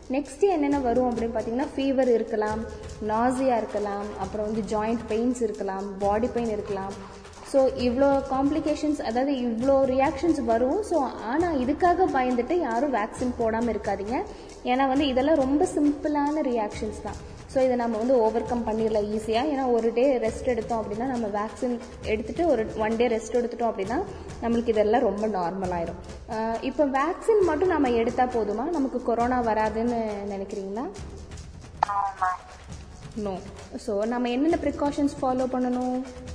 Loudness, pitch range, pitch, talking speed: -26 LUFS, 220-275 Hz, 245 Hz, 135 wpm